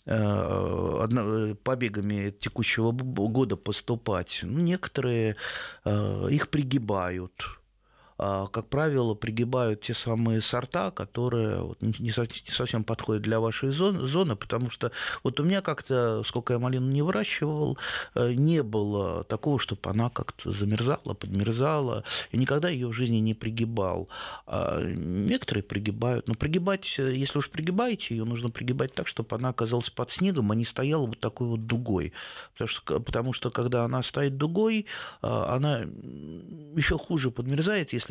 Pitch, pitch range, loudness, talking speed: 120 Hz, 110-140 Hz, -29 LUFS, 130 wpm